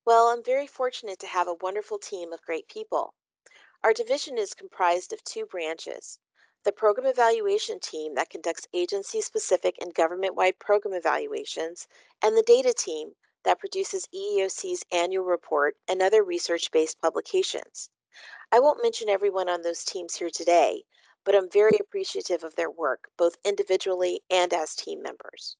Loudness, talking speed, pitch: -26 LUFS, 160 wpm, 230 Hz